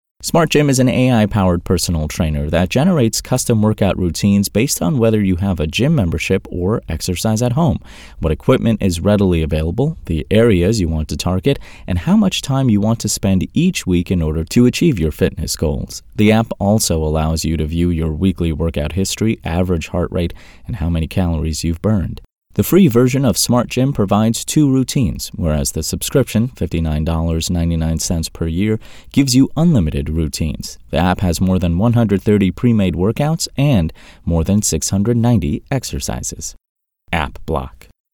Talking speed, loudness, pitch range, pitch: 175 wpm, -16 LUFS, 80-115 Hz, 95 Hz